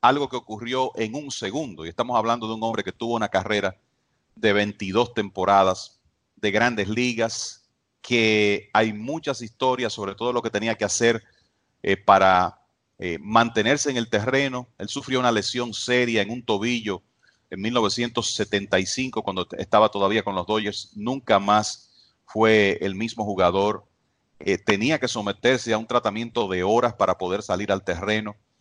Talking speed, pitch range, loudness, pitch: 160 wpm, 105-120 Hz, -23 LUFS, 110 Hz